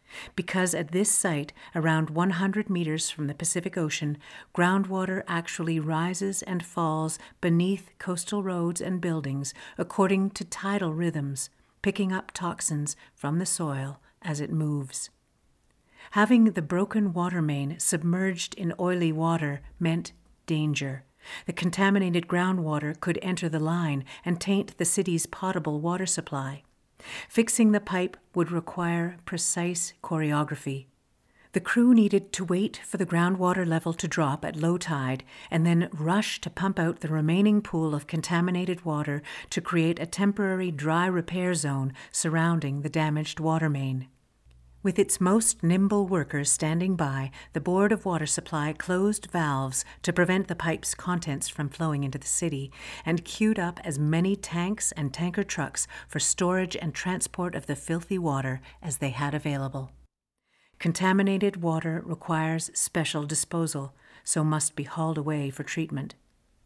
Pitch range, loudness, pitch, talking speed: 150-185 Hz, -27 LUFS, 170 Hz, 145 wpm